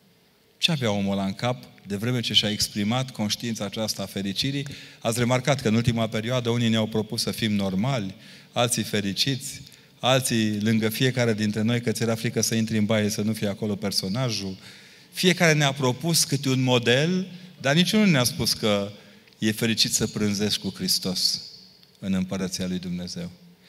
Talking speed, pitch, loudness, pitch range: 175 wpm, 115 Hz, -24 LUFS, 105-130 Hz